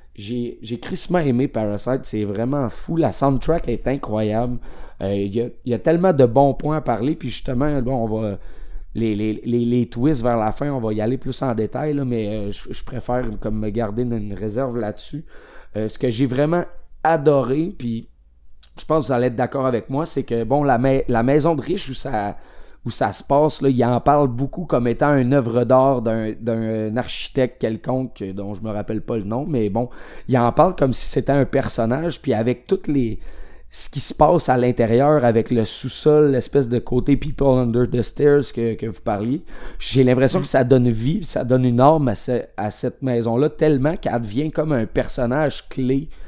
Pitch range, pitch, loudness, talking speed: 115-140 Hz, 125 Hz, -20 LUFS, 210 wpm